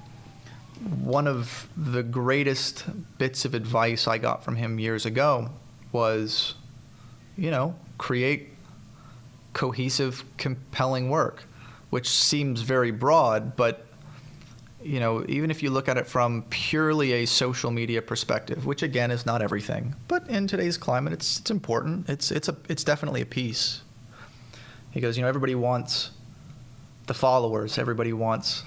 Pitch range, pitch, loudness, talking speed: 120-145 Hz, 130 Hz, -26 LUFS, 140 wpm